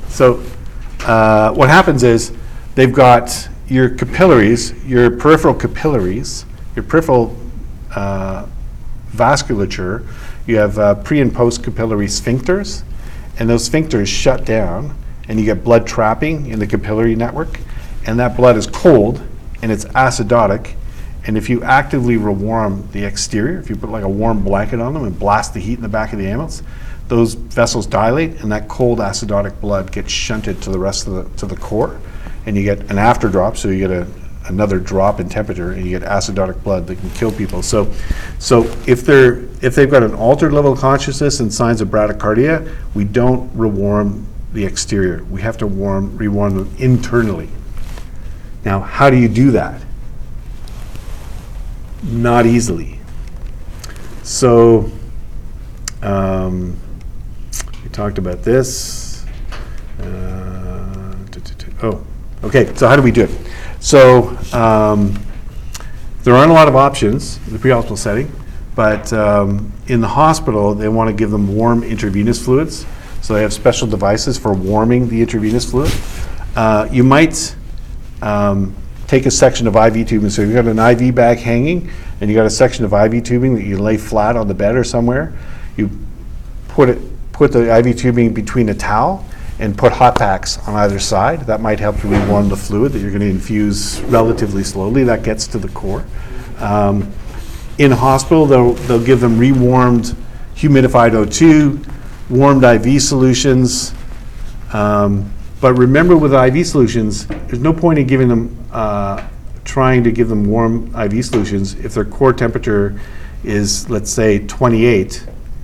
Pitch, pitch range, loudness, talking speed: 110 Hz, 100-125 Hz, -14 LUFS, 160 wpm